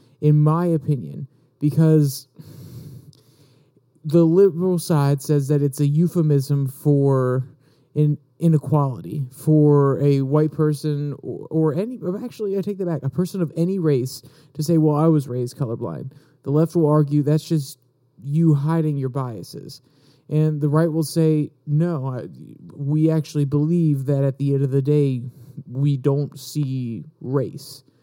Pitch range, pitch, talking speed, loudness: 140-160 Hz, 150 Hz, 150 wpm, -20 LUFS